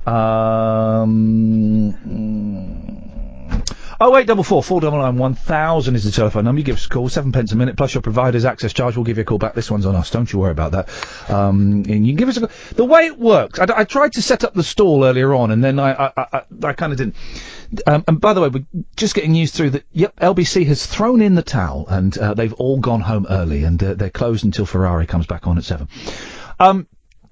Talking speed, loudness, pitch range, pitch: 245 wpm, -16 LUFS, 105-160 Hz, 120 Hz